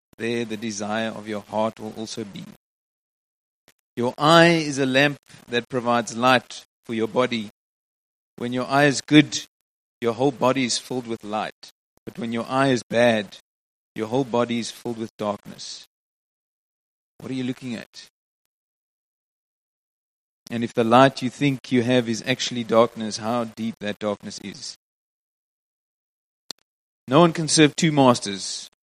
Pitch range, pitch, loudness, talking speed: 110-130 Hz, 120 Hz, -22 LUFS, 150 wpm